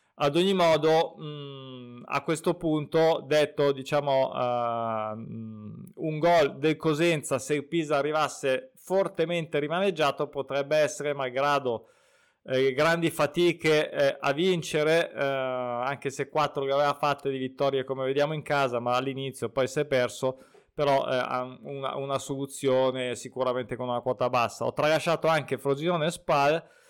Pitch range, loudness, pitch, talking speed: 130-155 Hz, -27 LUFS, 140 Hz, 125 wpm